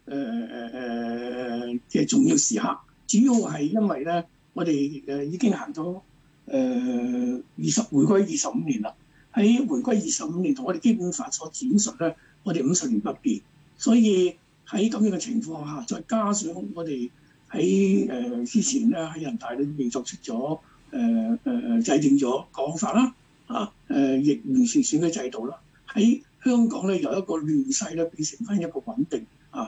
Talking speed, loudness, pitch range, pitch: 235 characters per minute, -25 LUFS, 150-245 Hz, 205 Hz